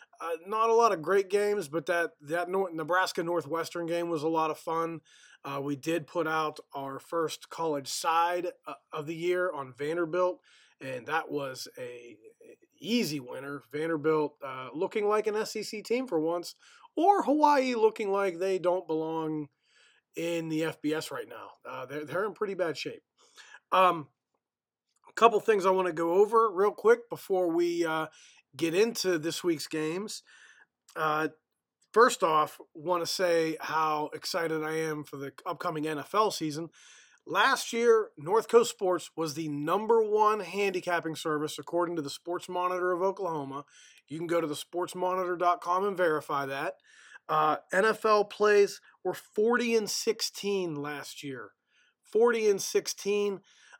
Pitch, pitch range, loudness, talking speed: 175 Hz, 155-205 Hz, -29 LUFS, 160 wpm